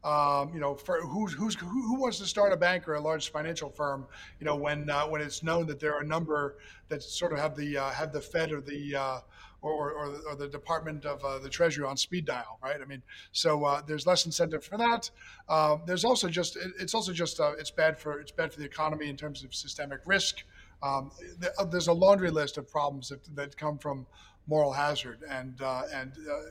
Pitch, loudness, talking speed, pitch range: 150 Hz, -31 LUFS, 235 wpm, 145-170 Hz